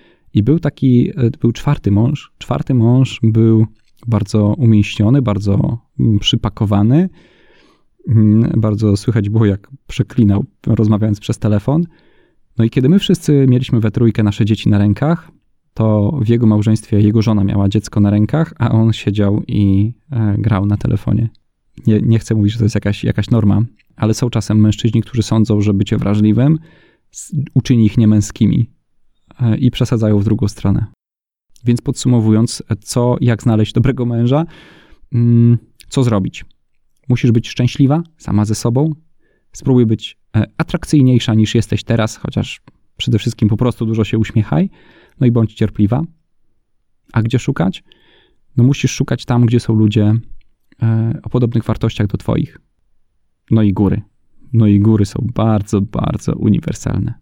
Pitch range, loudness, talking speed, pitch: 105-125 Hz, -15 LUFS, 145 wpm, 110 Hz